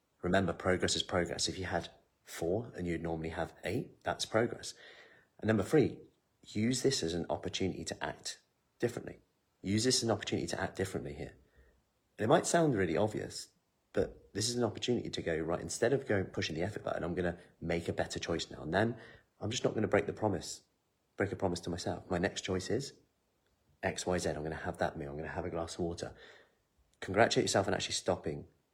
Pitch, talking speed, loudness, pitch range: 90 Hz, 210 wpm, -35 LUFS, 85-100 Hz